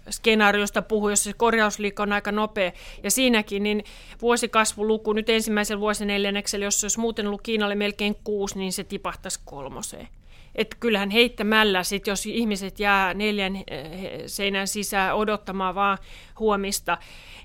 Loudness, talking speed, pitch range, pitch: -24 LUFS, 140 wpm, 200-215 Hz, 205 Hz